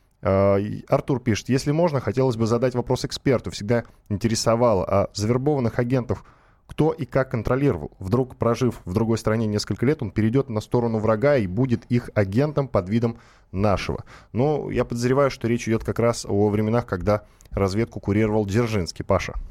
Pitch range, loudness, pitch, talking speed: 105-130 Hz, -23 LUFS, 115 Hz, 160 wpm